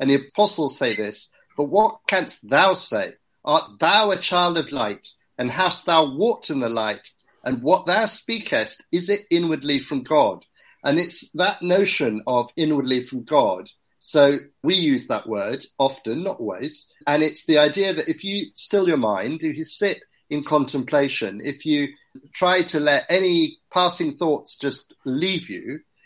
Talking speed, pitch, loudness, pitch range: 170 wpm, 160 Hz, -21 LUFS, 145-195 Hz